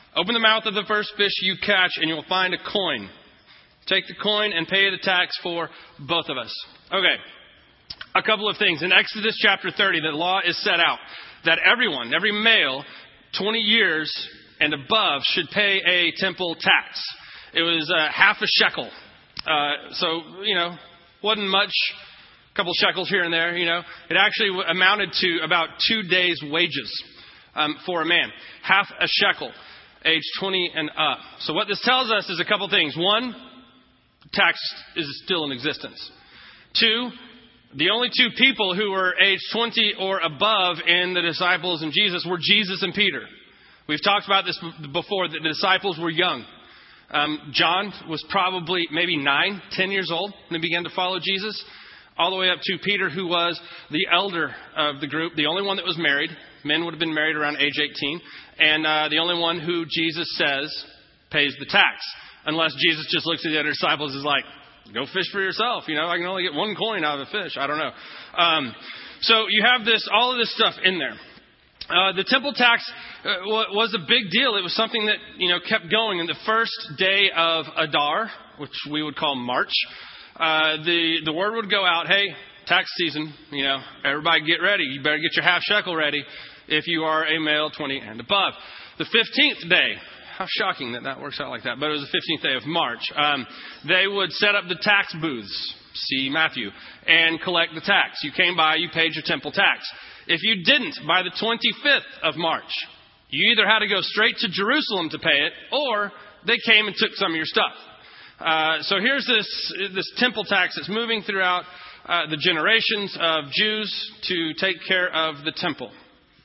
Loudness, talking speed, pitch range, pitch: -21 LUFS, 195 wpm, 160-205 Hz, 180 Hz